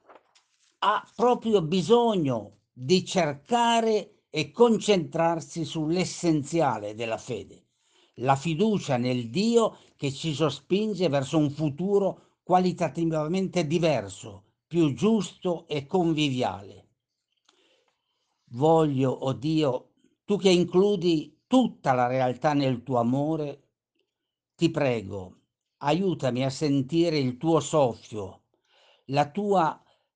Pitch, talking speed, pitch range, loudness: 160 Hz, 100 wpm, 135-185 Hz, -26 LUFS